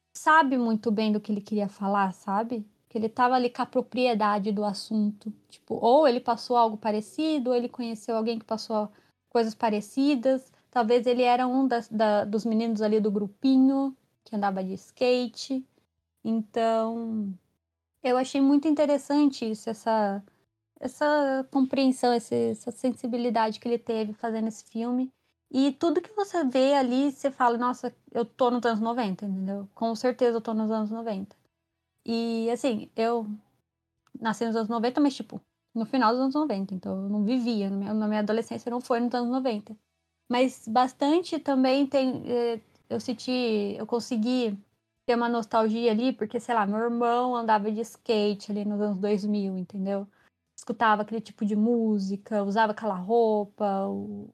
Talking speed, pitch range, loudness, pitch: 160 wpm, 210-250 Hz, -27 LUFS, 230 Hz